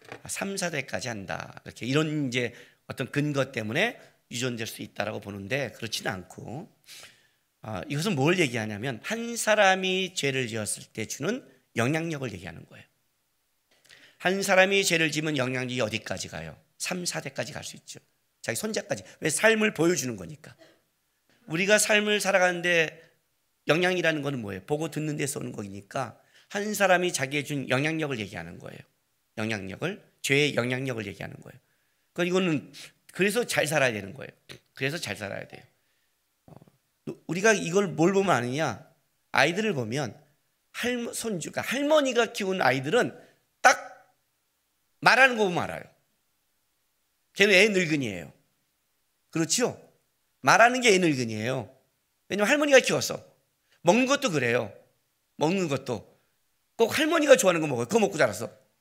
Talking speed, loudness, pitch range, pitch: 315 characters per minute, -26 LUFS, 115-185 Hz, 150 Hz